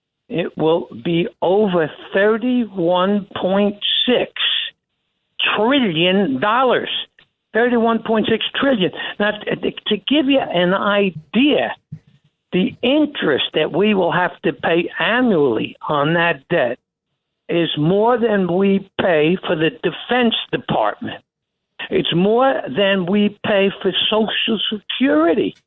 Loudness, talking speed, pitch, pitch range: -17 LUFS, 105 wpm, 200 Hz, 170-225 Hz